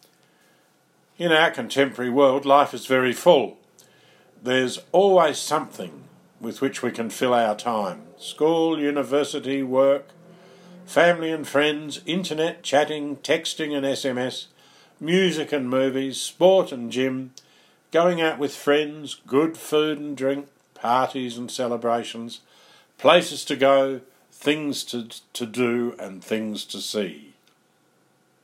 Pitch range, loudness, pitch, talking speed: 130-155 Hz, -22 LUFS, 140 Hz, 120 wpm